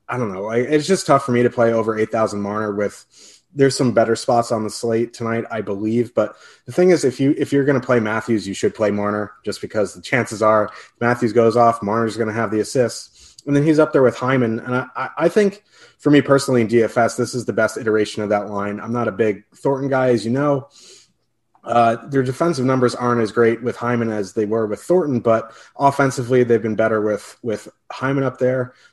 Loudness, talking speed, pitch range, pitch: -19 LUFS, 230 wpm, 110-130 Hz, 120 Hz